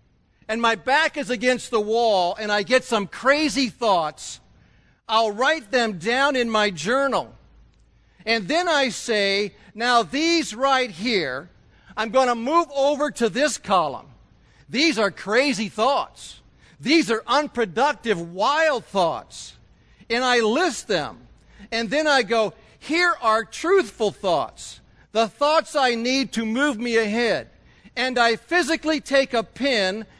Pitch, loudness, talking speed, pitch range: 240 Hz, -21 LUFS, 140 wpm, 220-280 Hz